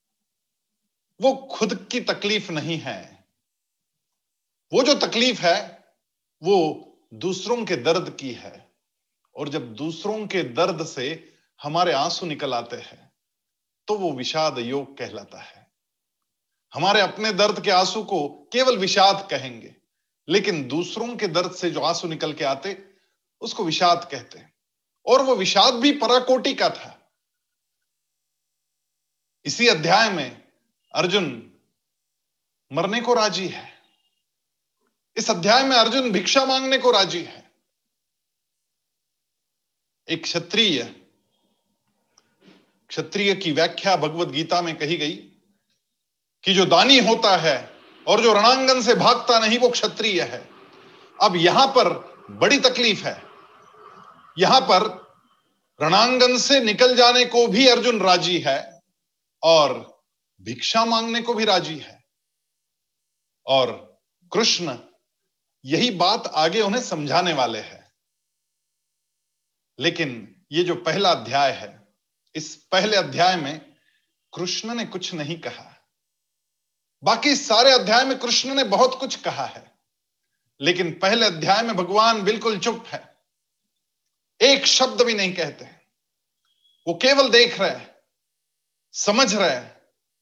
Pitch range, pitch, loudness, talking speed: 170-240 Hz, 195 Hz, -20 LUFS, 120 wpm